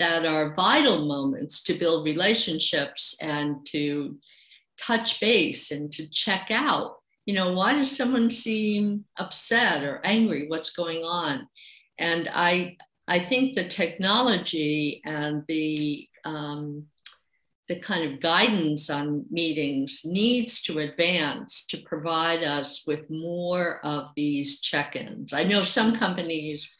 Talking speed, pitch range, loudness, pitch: 130 wpm, 150-195 Hz, -25 LUFS, 165 Hz